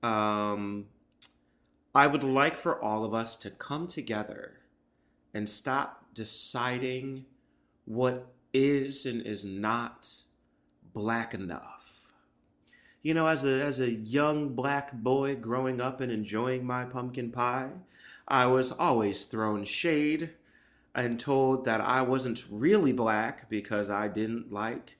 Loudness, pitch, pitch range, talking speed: -30 LUFS, 120 Hz, 105-130 Hz, 125 wpm